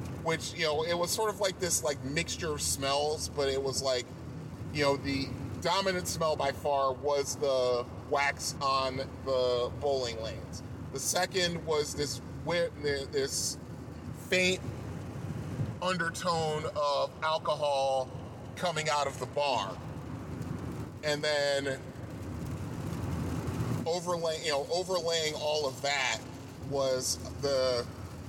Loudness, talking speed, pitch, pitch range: -32 LUFS, 120 wpm, 140 Hz, 130-160 Hz